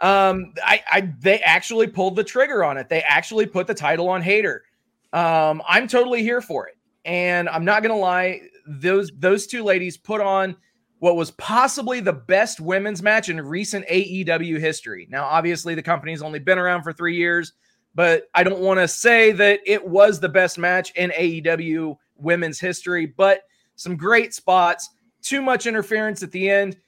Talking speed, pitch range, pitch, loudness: 185 wpm, 170-210 Hz, 185 Hz, -19 LUFS